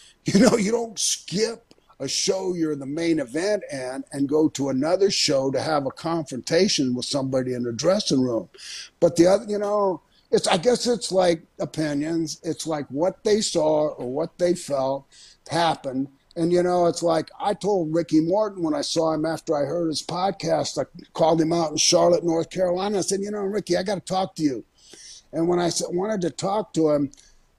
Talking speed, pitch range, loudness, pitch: 200 wpm, 150-190 Hz, -23 LUFS, 165 Hz